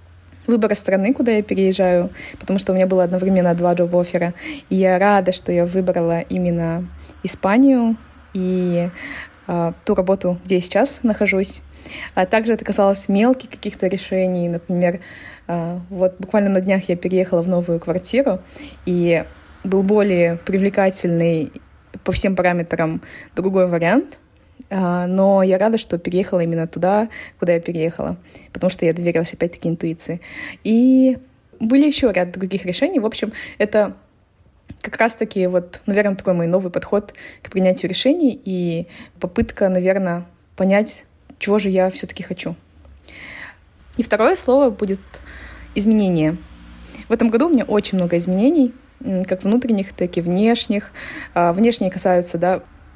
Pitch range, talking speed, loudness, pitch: 175-210 Hz, 140 wpm, -18 LUFS, 185 Hz